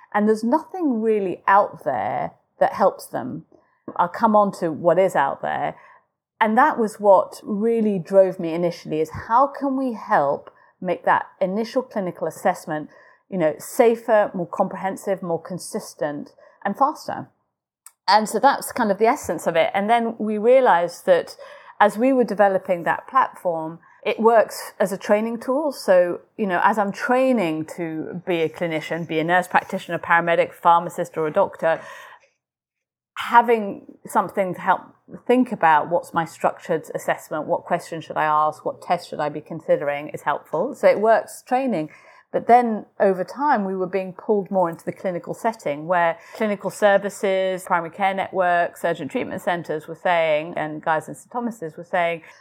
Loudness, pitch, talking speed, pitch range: -21 LUFS, 195 Hz, 170 wpm, 170-230 Hz